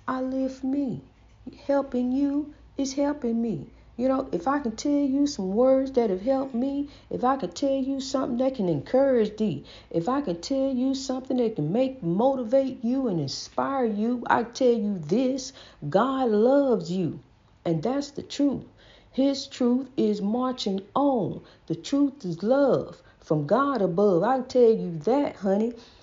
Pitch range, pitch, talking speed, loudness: 205-270 Hz, 255 Hz, 170 wpm, -26 LUFS